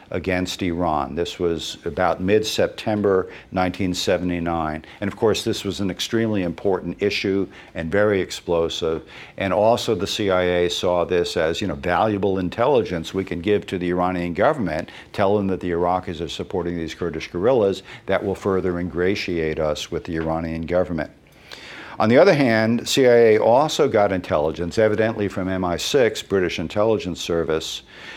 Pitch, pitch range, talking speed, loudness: 90 Hz, 85-100 Hz, 150 wpm, -21 LUFS